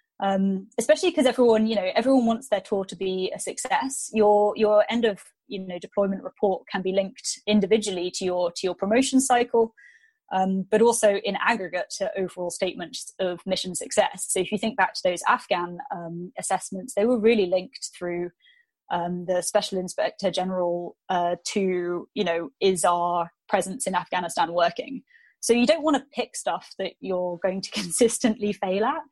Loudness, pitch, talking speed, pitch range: -25 LUFS, 200 Hz, 180 wpm, 185-230 Hz